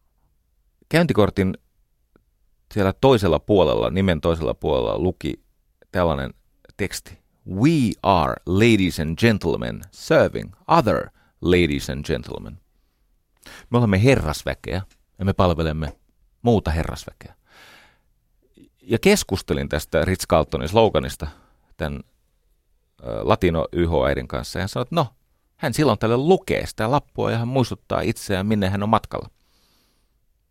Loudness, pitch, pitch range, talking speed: -21 LUFS, 95 Hz, 80-110 Hz, 110 wpm